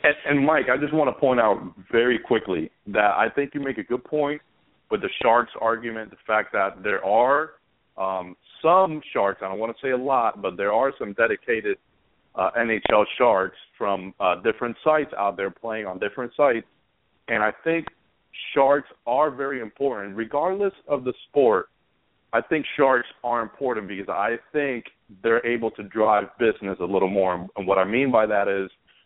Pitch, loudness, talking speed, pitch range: 120 Hz, -23 LUFS, 185 wpm, 100-145 Hz